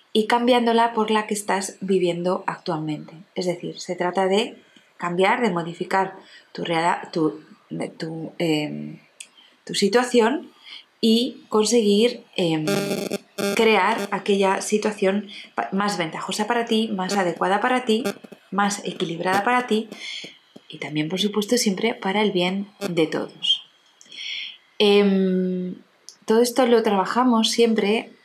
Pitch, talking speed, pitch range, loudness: 200 Hz, 120 wpm, 185-225 Hz, -22 LUFS